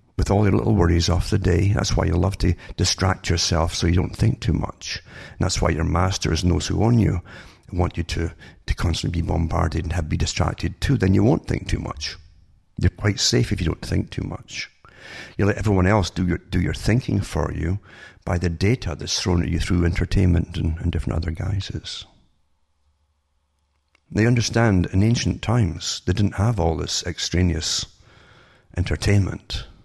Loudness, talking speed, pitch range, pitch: -22 LUFS, 190 wpm, 80-100 Hz, 90 Hz